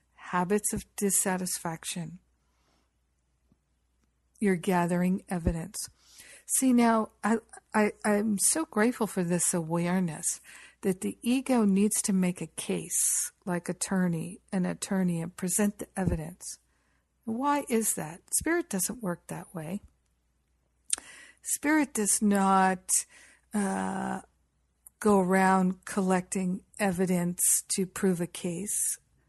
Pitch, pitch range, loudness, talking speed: 185 Hz, 170-210 Hz, -28 LUFS, 105 wpm